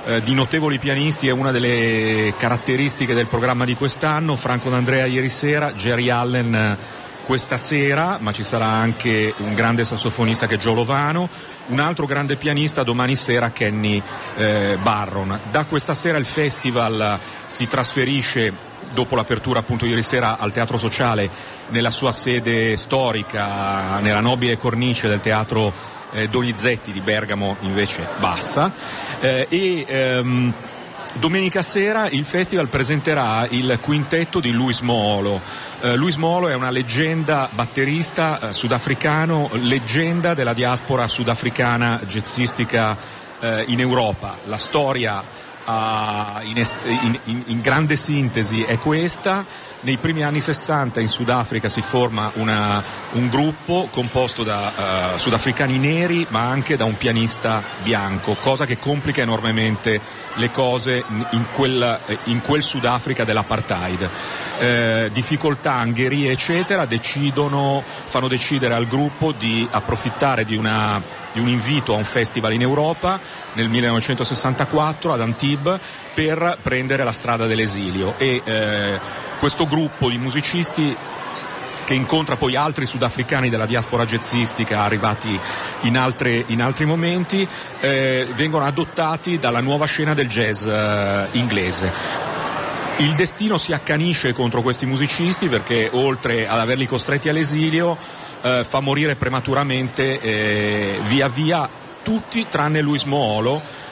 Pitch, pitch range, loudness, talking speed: 125 Hz, 115-145 Hz, -20 LUFS, 130 wpm